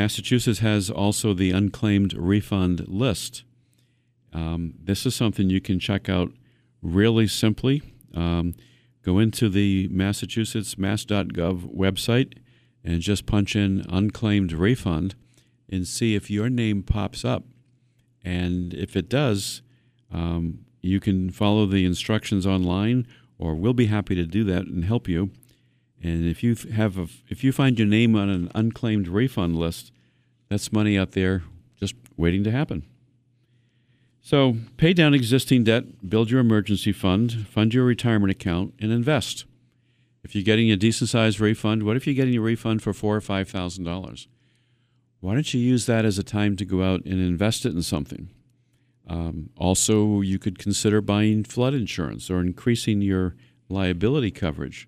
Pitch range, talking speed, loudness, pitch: 95-120 Hz, 155 wpm, -23 LUFS, 105 Hz